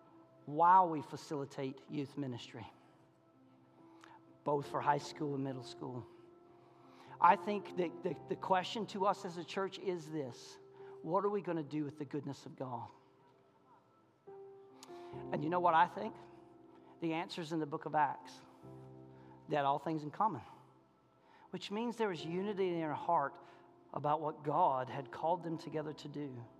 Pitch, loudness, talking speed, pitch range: 150 Hz, -37 LUFS, 160 wpm, 130-185 Hz